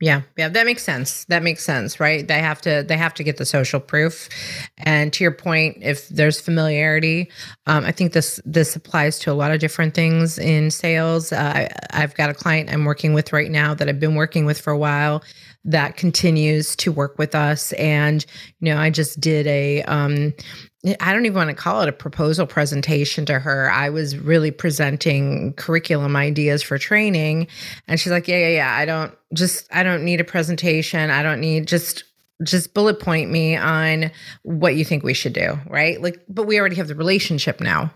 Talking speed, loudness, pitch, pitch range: 205 wpm, -19 LUFS, 155 Hz, 150-165 Hz